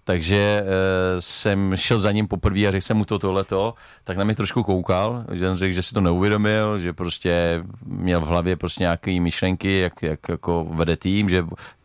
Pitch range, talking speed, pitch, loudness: 90-105 Hz, 200 wpm, 95 Hz, -22 LUFS